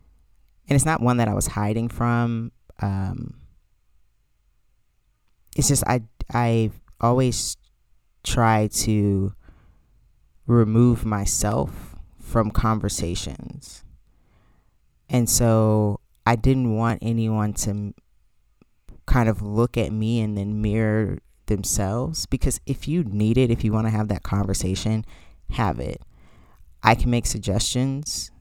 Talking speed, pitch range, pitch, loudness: 120 wpm, 95-120 Hz, 110 Hz, -23 LUFS